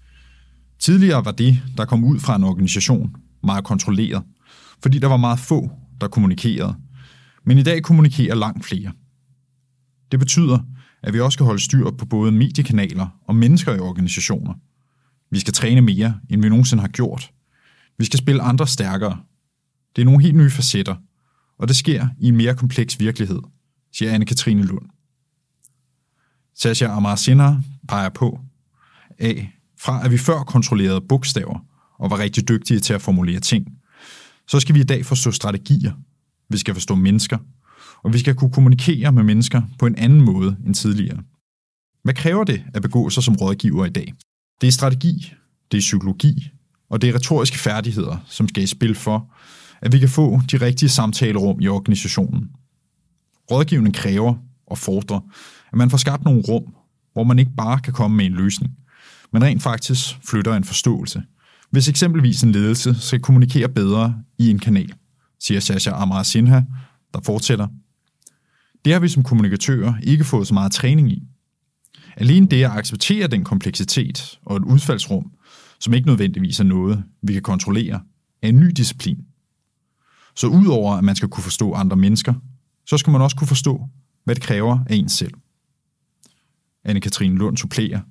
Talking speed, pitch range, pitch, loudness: 170 wpm, 105-135 Hz, 120 Hz, -17 LUFS